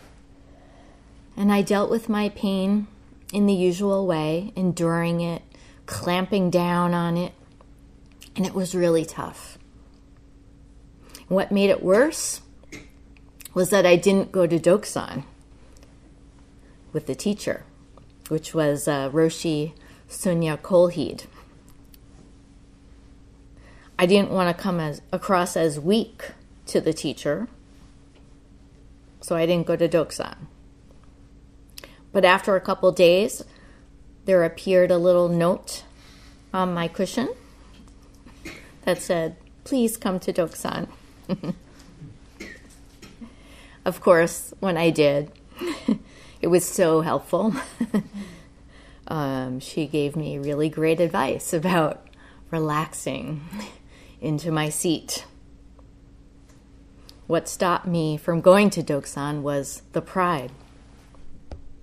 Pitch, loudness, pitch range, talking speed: 170 Hz, -23 LUFS, 150-190 Hz, 105 wpm